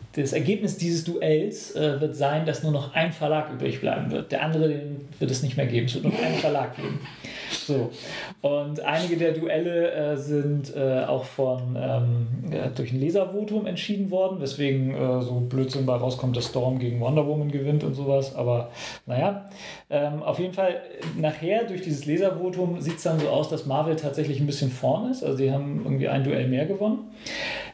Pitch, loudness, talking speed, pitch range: 150 Hz, -26 LUFS, 195 wpm, 135-170 Hz